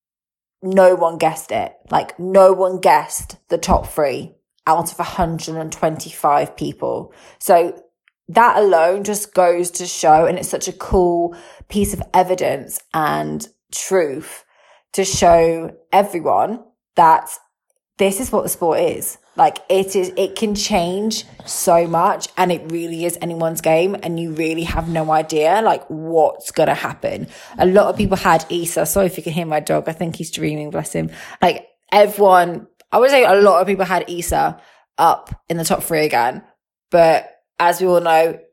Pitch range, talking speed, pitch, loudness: 160-190 Hz, 170 wpm, 175 Hz, -17 LUFS